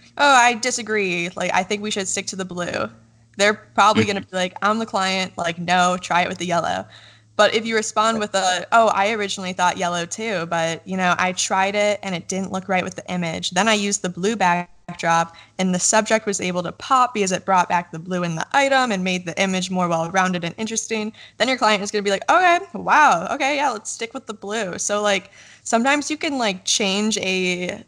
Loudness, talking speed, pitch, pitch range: -20 LUFS, 235 wpm, 190 Hz, 180-215 Hz